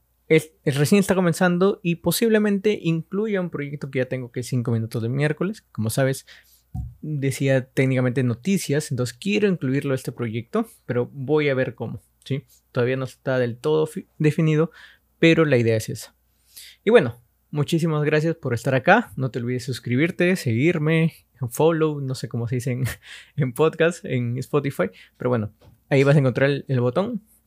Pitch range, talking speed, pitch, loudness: 125-165 Hz, 175 wpm, 140 Hz, -22 LUFS